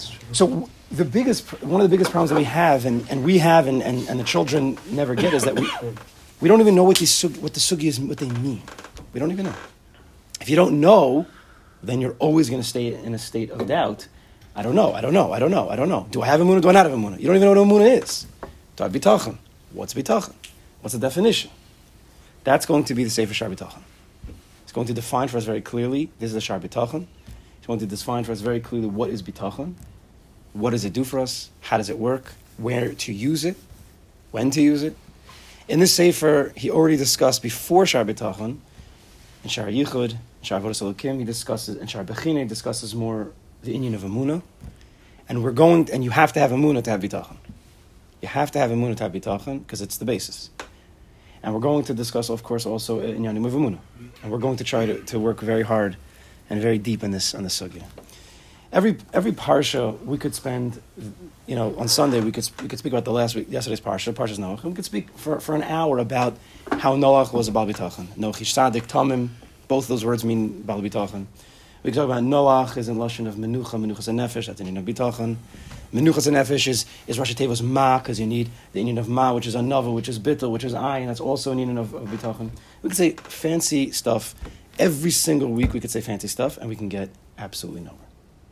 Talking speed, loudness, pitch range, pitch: 230 wpm, -22 LUFS, 110-140 Hz, 120 Hz